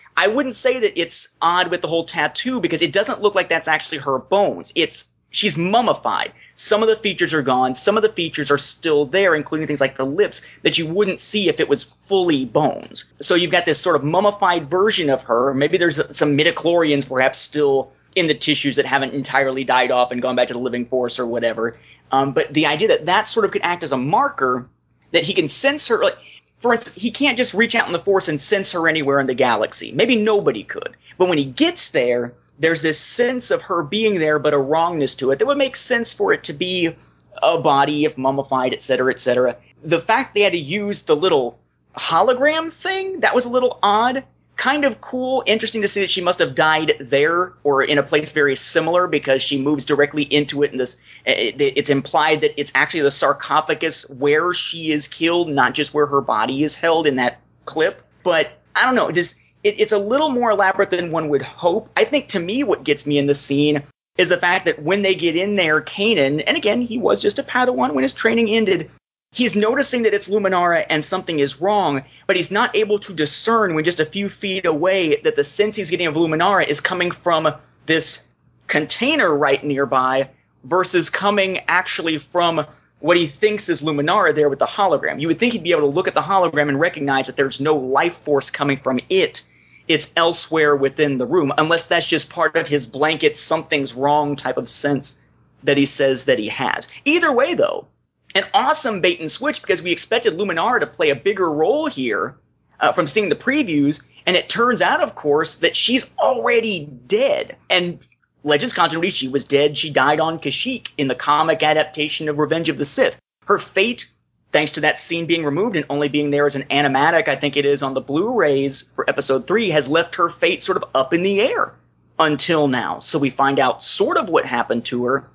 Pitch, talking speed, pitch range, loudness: 165 Hz, 220 wpm, 145-205 Hz, -18 LUFS